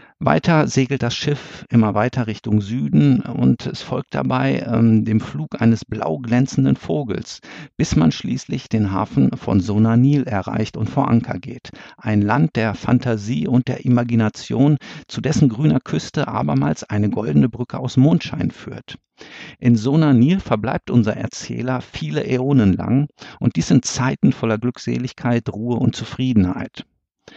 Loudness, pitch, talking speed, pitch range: -19 LUFS, 120 Hz, 145 wpm, 110-130 Hz